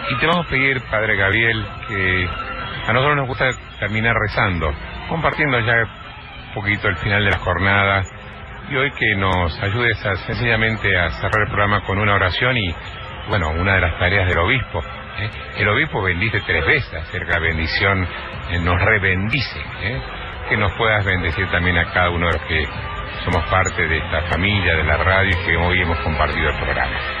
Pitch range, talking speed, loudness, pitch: 85-110 Hz, 185 wpm, -18 LUFS, 95 Hz